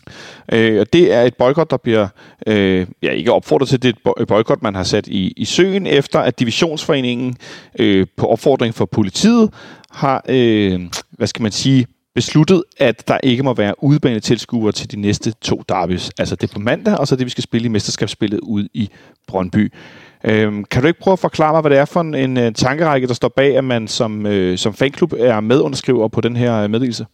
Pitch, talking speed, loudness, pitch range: 120 Hz, 210 wpm, -16 LUFS, 105-135 Hz